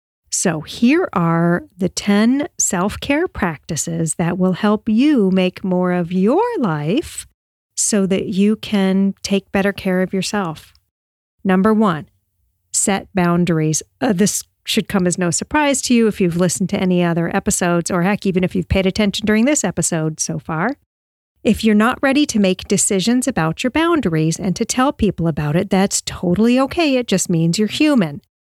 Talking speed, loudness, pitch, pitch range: 175 wpm, -17 LUFS, 195 Hz, 175-220 Hz